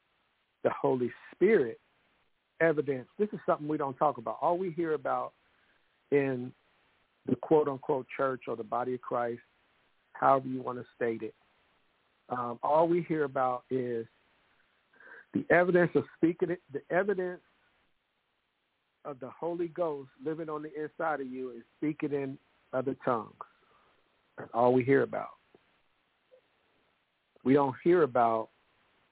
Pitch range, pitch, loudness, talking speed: 125-165 Hz, 140 Hz, -31 LUFS, 140 wpm